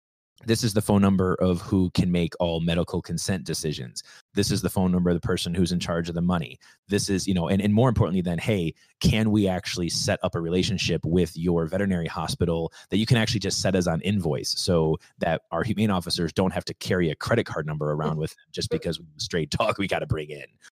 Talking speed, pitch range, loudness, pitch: 235 wpm, 85-100 Hz, -25 LUFS, 90 Hz